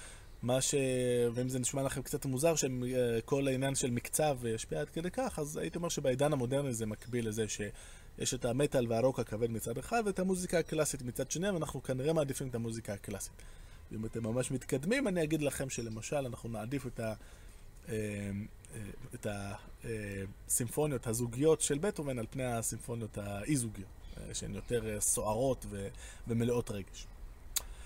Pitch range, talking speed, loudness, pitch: 105-140 Hz, 150 wpm, -35 LUFS, 120 Hz